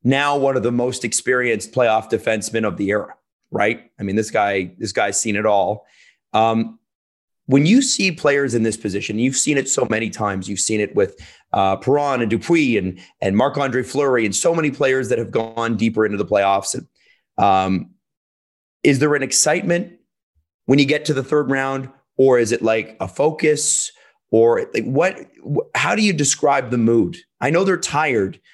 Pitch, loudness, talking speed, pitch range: 120 Hz, -18 LUFS, 190 wpm, 105-145 Hz